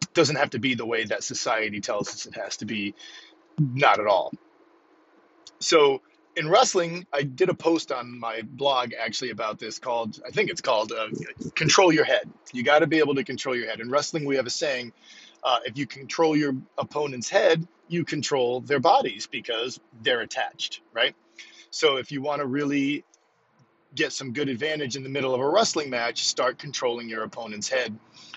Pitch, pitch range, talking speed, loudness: 140 Hz, 120-155 Hz, 195 wpm, -25 LUFS